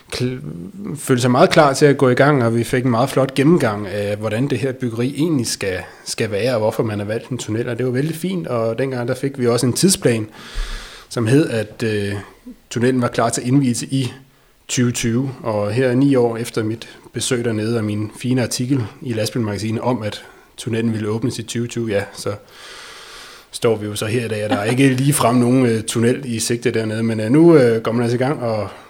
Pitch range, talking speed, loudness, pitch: 115-135 Hz, 230 wpm, -18 LUFS, 120 Hz